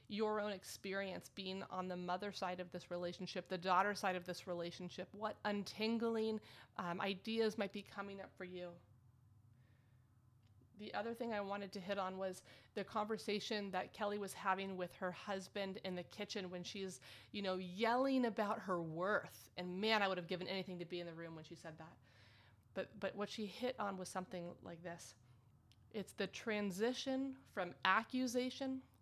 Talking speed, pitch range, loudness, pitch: 180 wpm, 175-210 Hz, -43 LUFS, 190 Hz